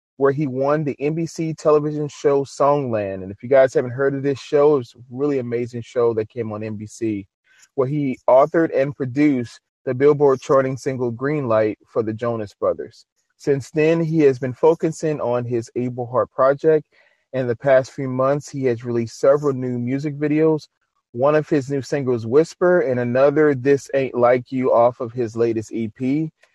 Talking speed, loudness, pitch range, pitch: 185 wpm, -20 LUFS, 120-145 Hz, 135 Hz